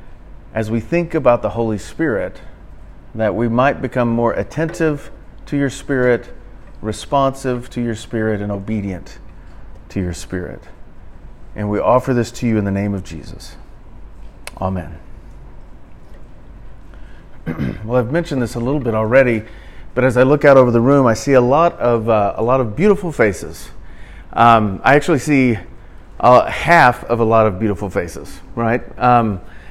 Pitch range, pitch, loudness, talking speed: 100-130 Hz, 115 Hz, -16 LUFS, 160 wpm